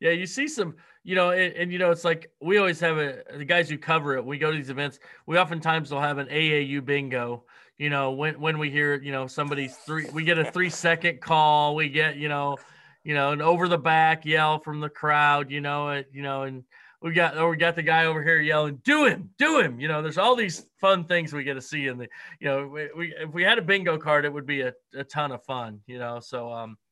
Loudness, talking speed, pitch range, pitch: -24 LUFS, 260 wpm, 140-170 Hz, 155 Hz